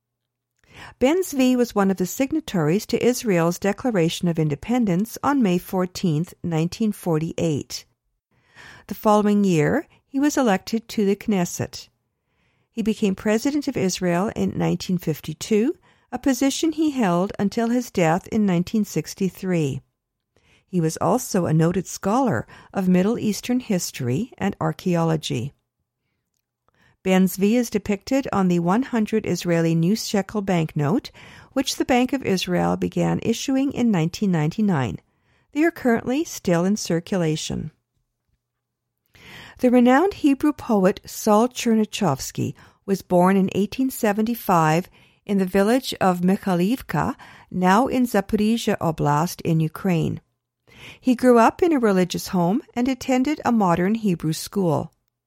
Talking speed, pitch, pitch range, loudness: 125 wpm, 195 Hz, 165-235 Hz, -22 LUFS